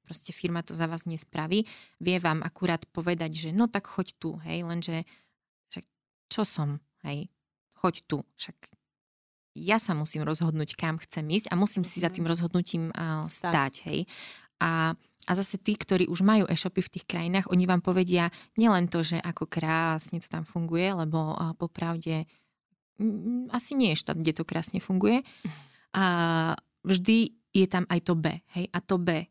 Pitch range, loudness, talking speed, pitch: 165-190 Hz, -28 LUFS, 175 wpm, 175 Hz